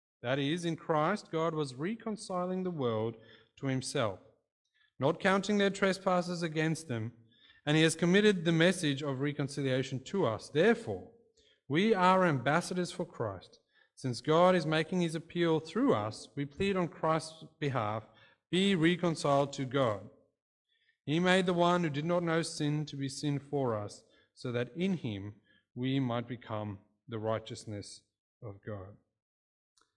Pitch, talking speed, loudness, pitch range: 150 Hz, 150 wpm, -32 LUFS, 120-180 Hz